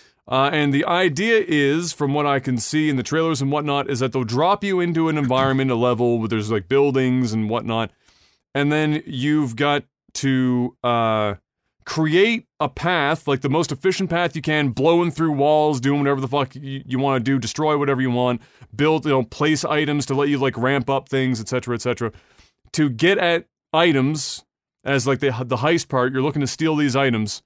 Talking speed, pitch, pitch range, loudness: 210 wpm, 140 Hz, 130-155 Hz, -20 LUFS